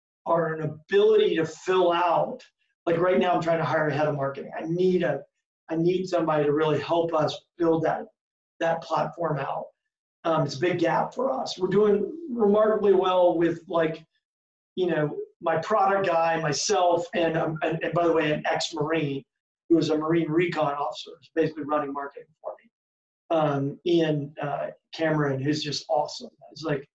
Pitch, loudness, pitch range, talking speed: 165 Hz, -25 LUFS, 155-180 Hz, 180 wpm